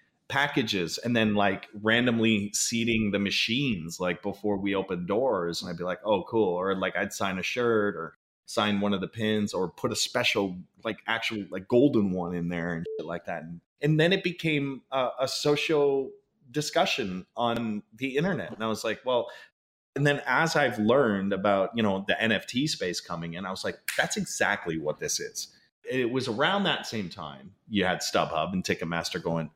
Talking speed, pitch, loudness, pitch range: 195 wpm, 110 Hz, -28 LUFS, 95-140 Hz